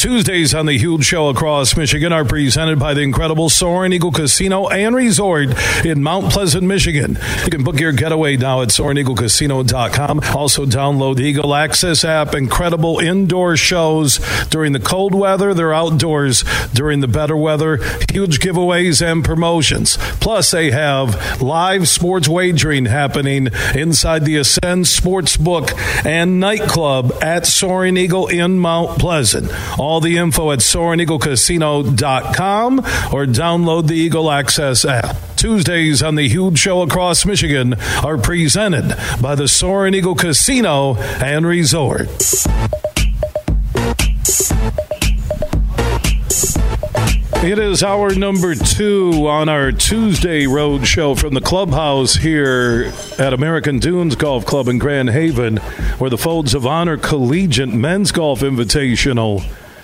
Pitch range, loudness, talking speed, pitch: 135-175 Hz, -14 LUFS, 130 wpm, 155 Hz